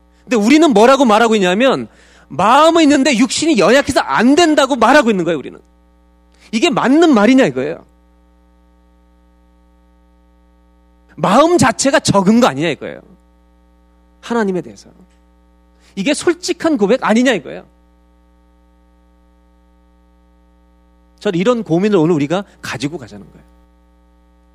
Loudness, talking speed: -13 LUFS, 270 characters per minute